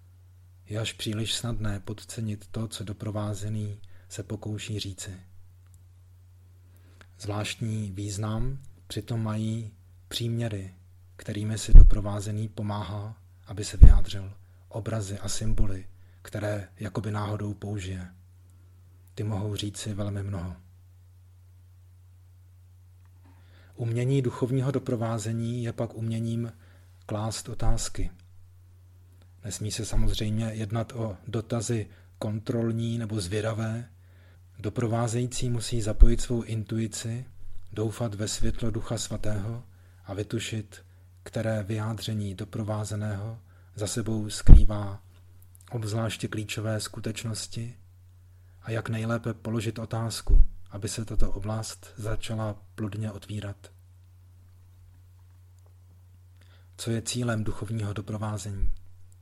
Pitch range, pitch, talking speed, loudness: 90-110 Hz, 105 Hz, 90 wpm, -30 LUFS